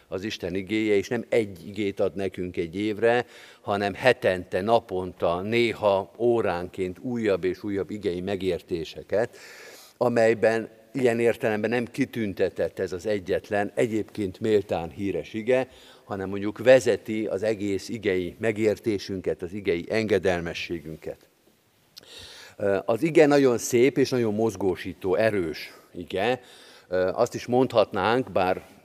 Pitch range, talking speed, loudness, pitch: 100-125 Hz, 115 wpm, -25 LUFS, 110 Hz